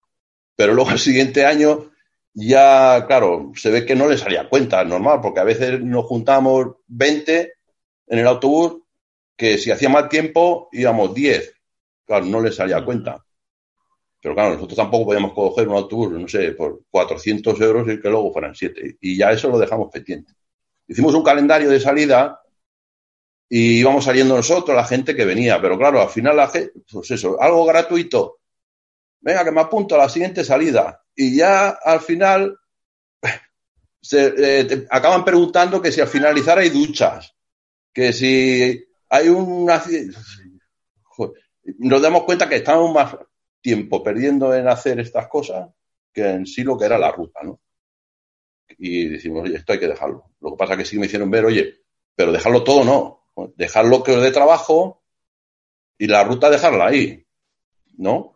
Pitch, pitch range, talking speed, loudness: 135 Hz, 115-170 Hz, 170 wpm, -16 LUFS